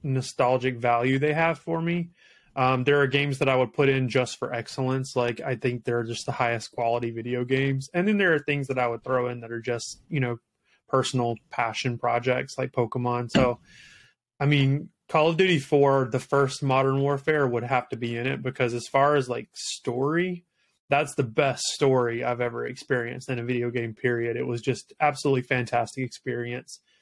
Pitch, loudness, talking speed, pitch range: 130 Hz, -26 LUFS, 200 wpm, 120-140 Hz